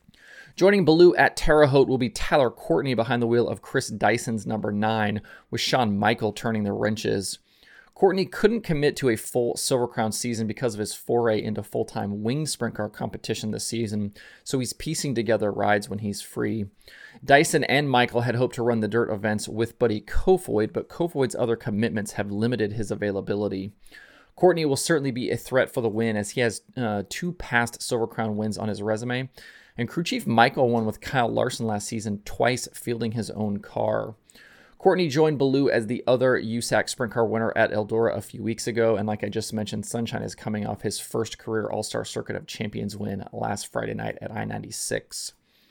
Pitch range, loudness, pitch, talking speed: 105-125 Hz, -25 LUFS, 115 Hz, 195 wpm